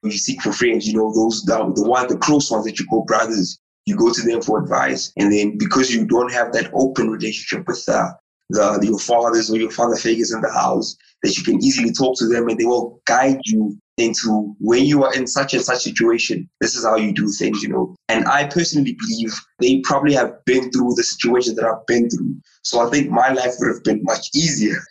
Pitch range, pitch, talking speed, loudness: 110-130 Hz, 120 Hz, 240 wpm, -18 LUFS